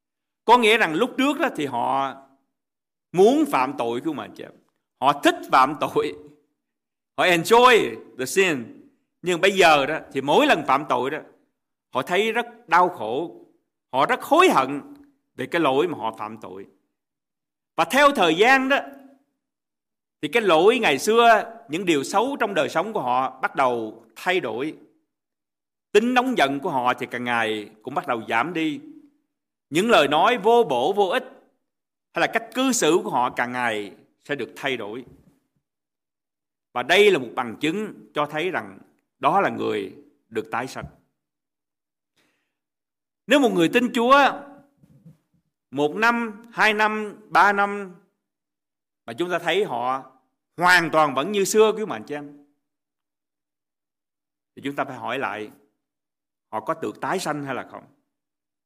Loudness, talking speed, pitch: -21 LUFS, 160 wpm, 200 Hz